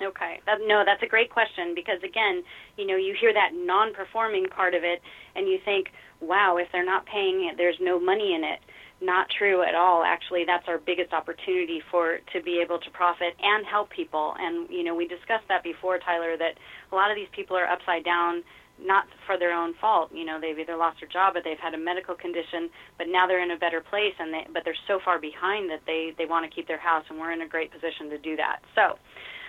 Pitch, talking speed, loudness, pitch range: 175 Hz, 235 wpm, -26 LUFS, 170-205 Hz